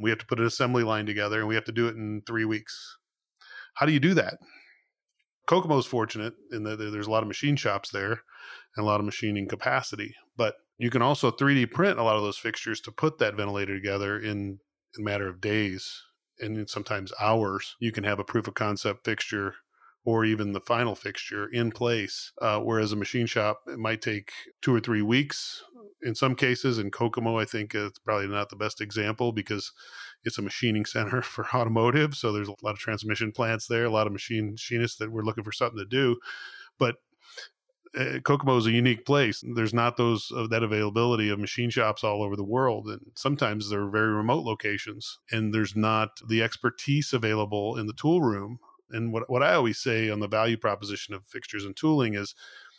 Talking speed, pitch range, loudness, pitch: 210 wpm, 105-120 Hz, -28 LUFS, 110 Hz